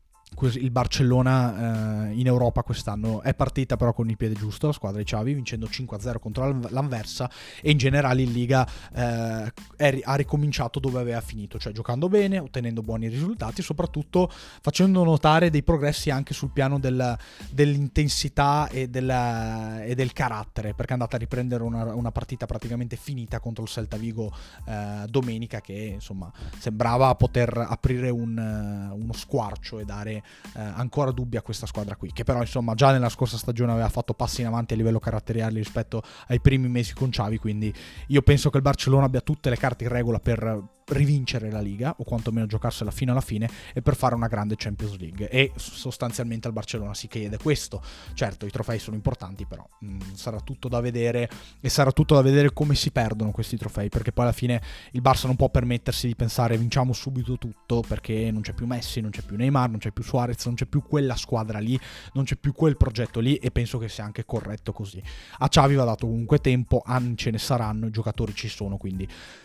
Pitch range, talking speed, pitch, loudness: 110-130 Hz, 195 wpm, 120 Hz, -25 LUFS